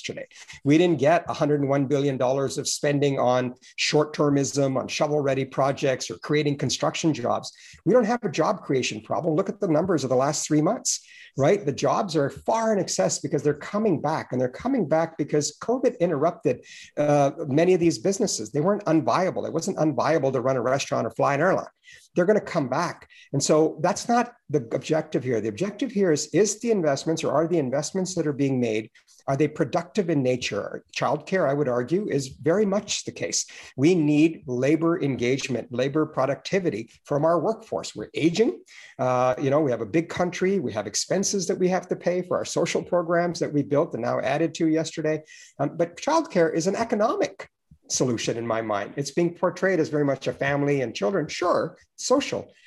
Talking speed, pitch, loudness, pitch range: 195 wpm, 155 Hz, -24 LUFS, 140-180 Hz